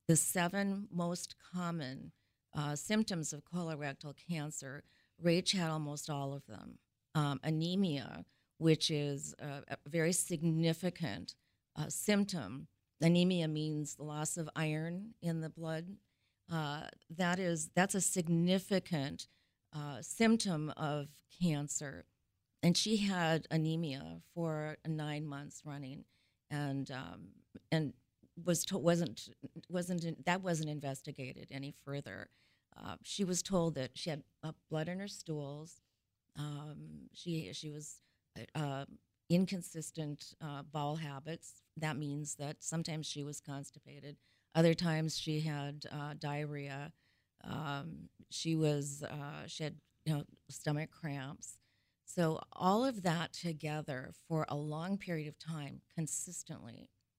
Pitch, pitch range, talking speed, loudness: 155 Hz, 145-170 Hz, 125 wpm, -38 LUFS